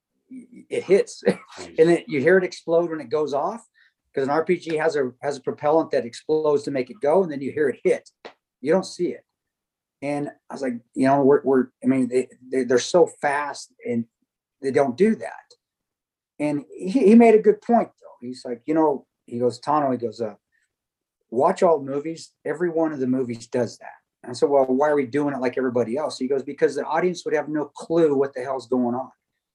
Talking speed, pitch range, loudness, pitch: 225 wpm, 130-175 Hz, -22 LUFS, 150 Hz